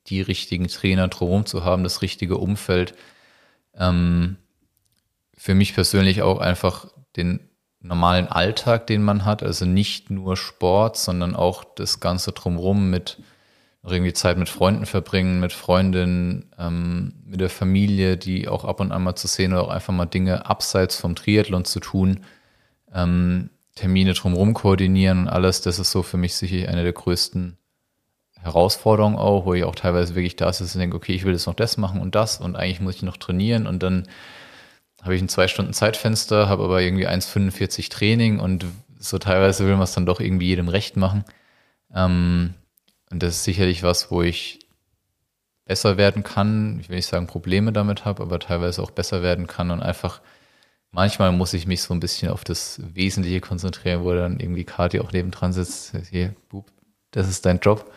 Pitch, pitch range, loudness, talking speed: 95 Hz, 90-100 Hz, -21 LUFS, 180 wpm